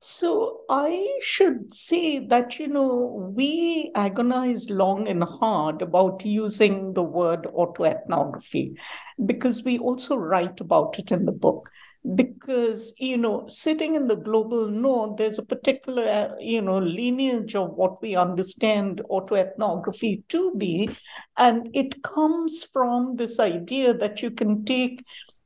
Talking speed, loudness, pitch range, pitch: 135 wpm, -24 LUFS, 205-265 Hz, 235 Hz